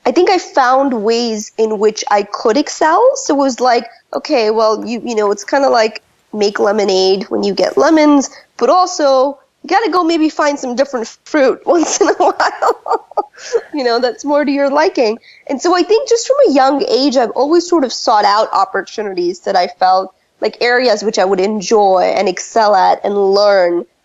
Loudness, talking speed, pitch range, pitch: -13 LUFS, 200 wpm, 210-315 Hz, 260 Hz